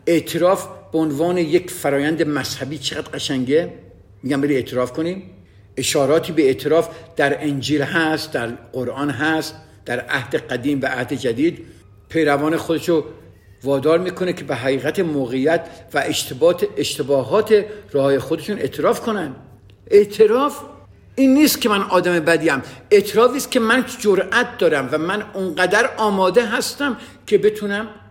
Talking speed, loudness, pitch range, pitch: 135 wpm, -19 LUFS, 140-205 Hz, 160 Hz